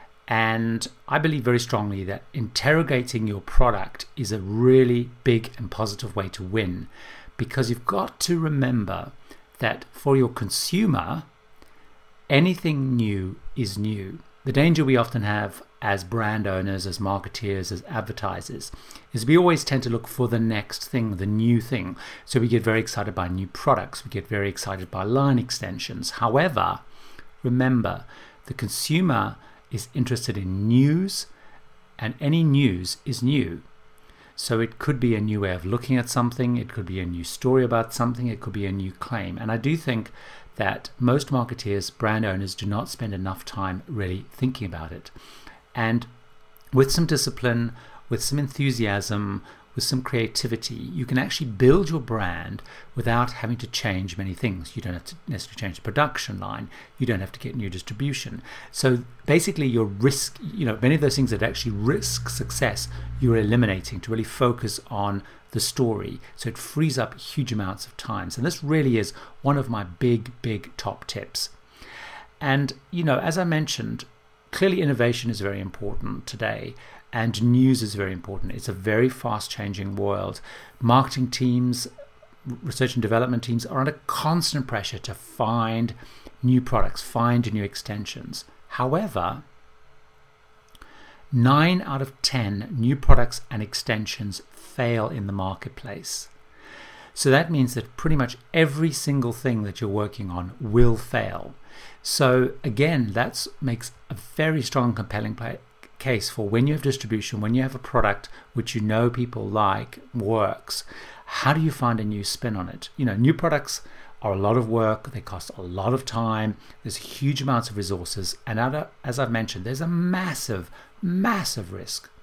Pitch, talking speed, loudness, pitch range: 120 Hz, 165 wpm, -25 LUFS, 105-130 Hz